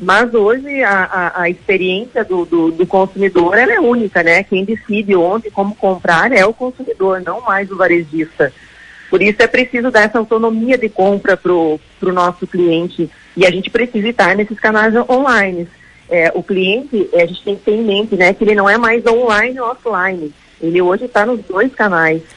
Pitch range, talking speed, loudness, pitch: 180-225 Hz, 195 wpm, -13 LUFS, 195 Hz